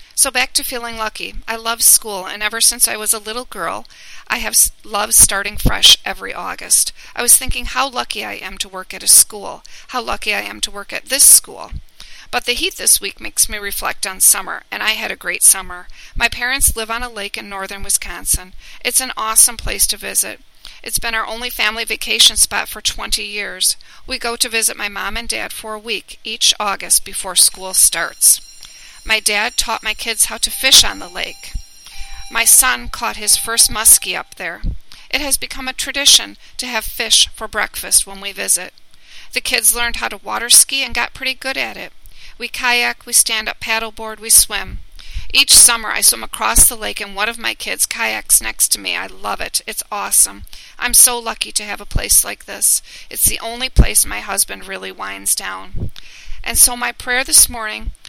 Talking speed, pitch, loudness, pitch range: 205 wpm, 225 Hz, -13 LUFS, 205-245 Hz